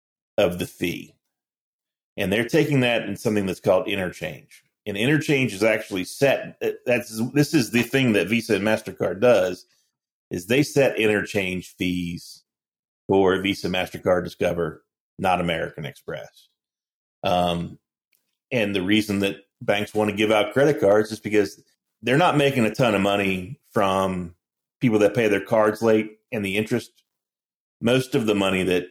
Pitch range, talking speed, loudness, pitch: 100-120 Hz, 160 wpm, -22 LUFS, 105 Hz